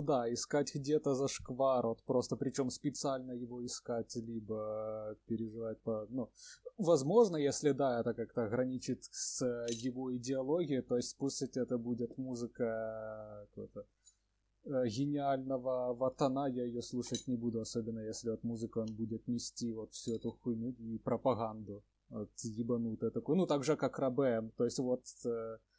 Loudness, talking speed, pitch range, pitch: -37 LUFS, 145 wpm, 115-135 Hz, 120 Hz